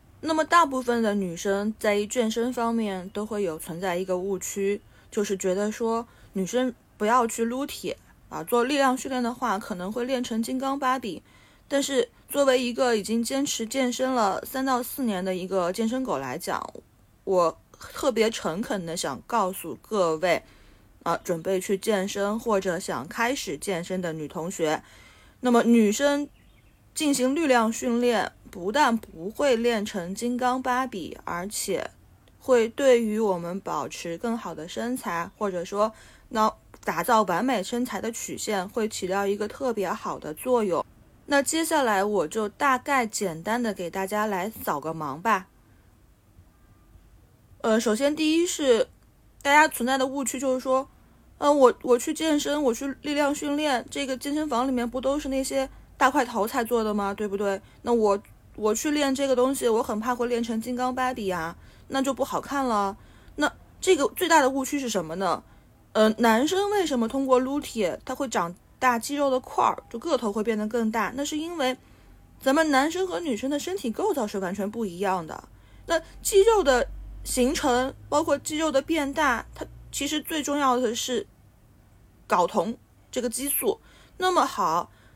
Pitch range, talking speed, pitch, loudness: 200-270 Hz, 245 characters per minute, 240 Hz, -26 LUFS